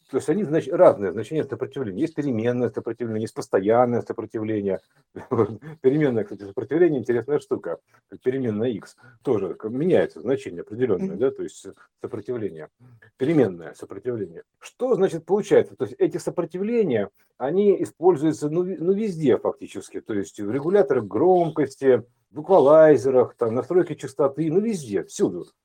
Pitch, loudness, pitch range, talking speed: 160 Hz, -23 LUFS, 125-205 Hz, 125 wpm